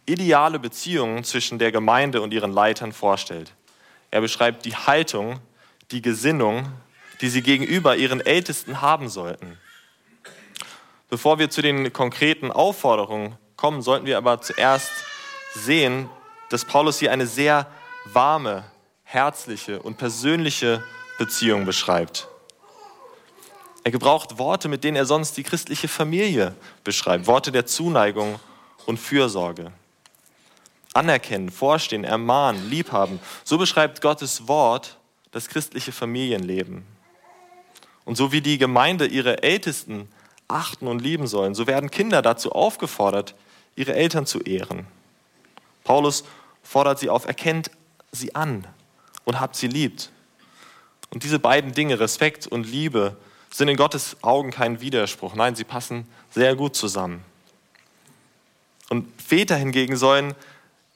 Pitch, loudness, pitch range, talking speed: 130 Hz, -22 LUFS, 115-150 Hz, 125 wpm